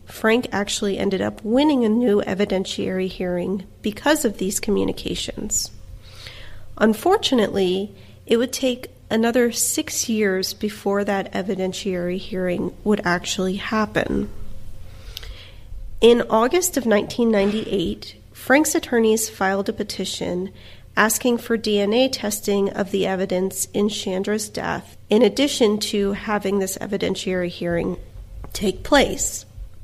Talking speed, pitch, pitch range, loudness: 110 wpm, 200 Hz, 180-220 Hz, -21 LUFS